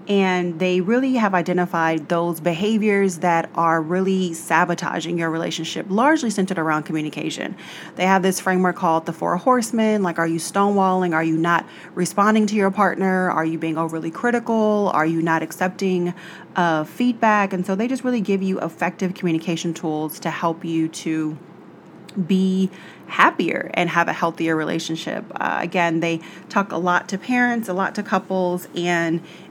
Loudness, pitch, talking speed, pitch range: -21 LUFS, 180 Hz, 165 wpm, 165-195 Hz